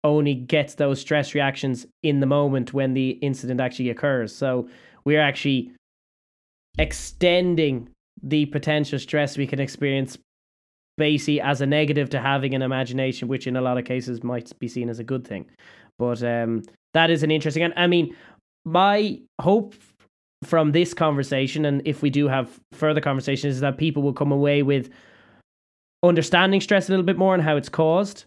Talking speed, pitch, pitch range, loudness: 175 wpm, 140 Hz, 130-155 Hz, -22 LUFS